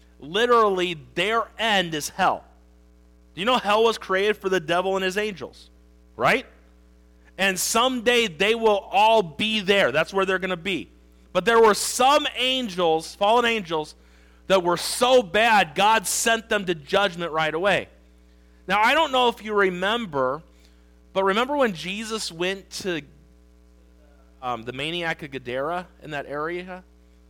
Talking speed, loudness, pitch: 155 wpm, -22 LUFS, 180 Hz